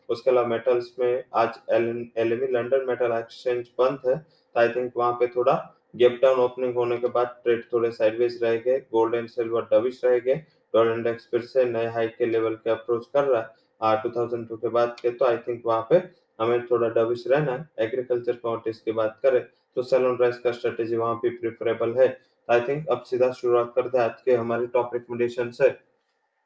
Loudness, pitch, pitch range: -24 LUFS, 120 Hz, 115-125 Hz